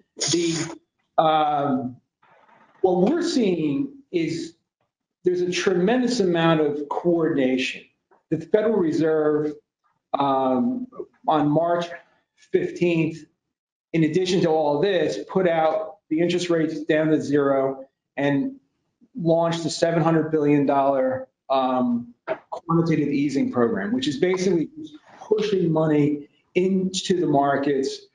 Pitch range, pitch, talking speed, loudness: 145-190 Hz, 165 Hz, 105 wpm, -22 LUFS